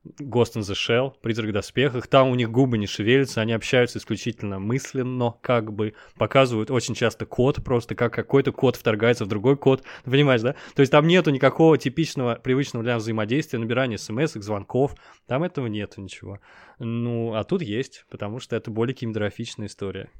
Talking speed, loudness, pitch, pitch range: 180 wpm, -23 LUFS, 120 Hz, 110-135 Hz